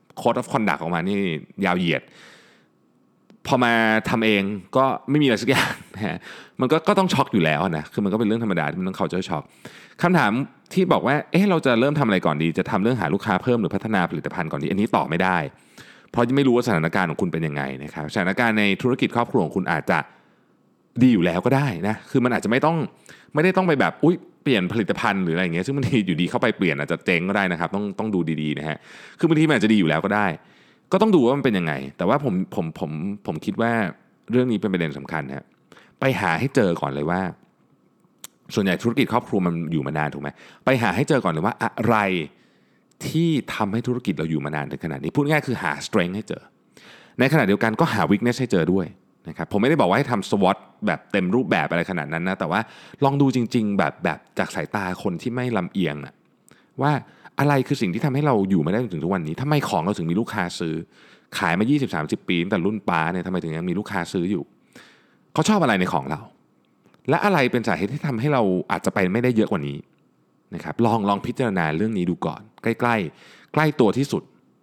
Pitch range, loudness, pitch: 85-125 Hz, -22 LUFS, 105 Hz